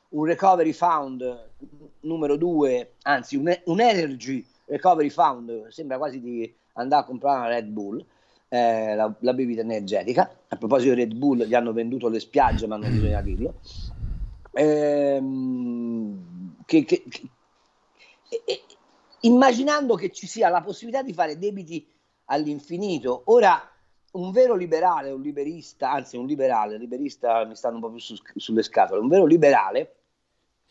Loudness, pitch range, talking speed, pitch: -23 LUFS, 115-180 Hz, 145 wpm, 140 Hz